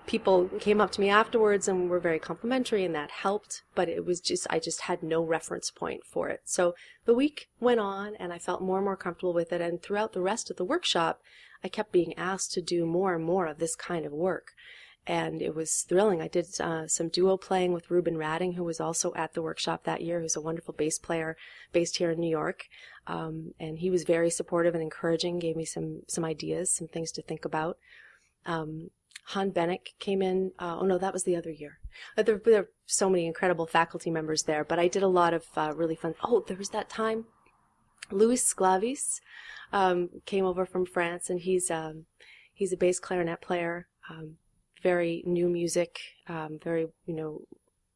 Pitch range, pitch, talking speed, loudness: 165-190 Hz, 175 Hz, 210 wpm, -29 LUFS